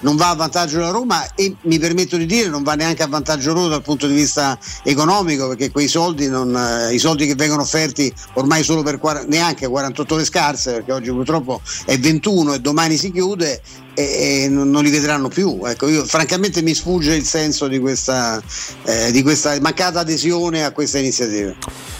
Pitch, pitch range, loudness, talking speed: 150 Hz, 140-165 Hz, -17 LUFS, 195 wpm